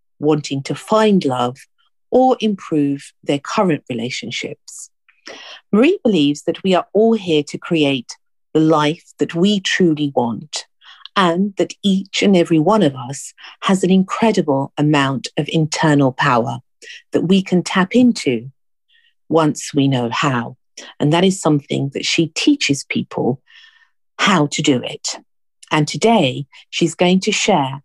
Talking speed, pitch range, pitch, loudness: 140 wpm, 145-200 Hz, 165 Hz, -17 LUFS